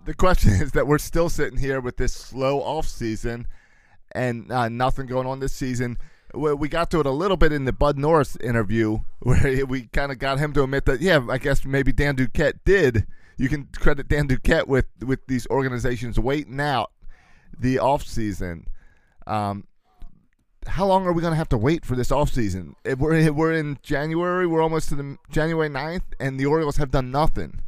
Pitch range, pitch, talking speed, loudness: 125-155 Hz, 135 Hz, 205 wpm, -23 LUFS